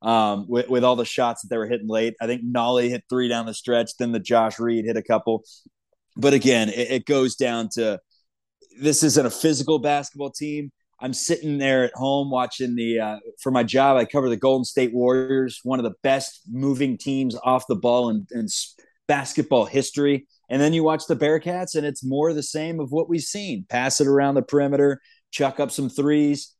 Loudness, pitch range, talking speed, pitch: -22 LUFS, 120-145 Hz, 210 wpm, 130 Hz